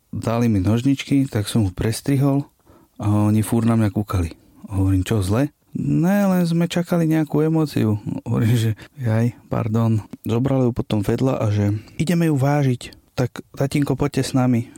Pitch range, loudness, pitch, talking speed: 110-140 Hz, -20 LUFS, 120 Hz, 160 wpm